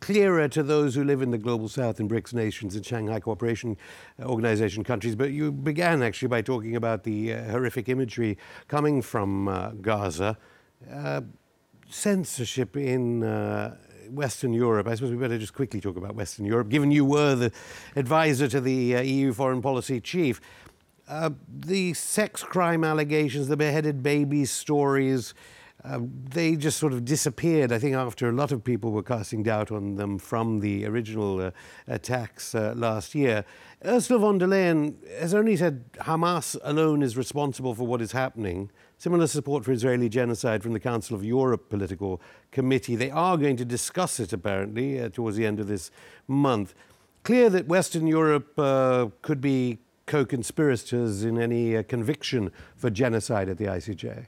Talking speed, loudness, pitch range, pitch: 170 wpm, -26 LUFS, 110-145 Hz, 125 Hz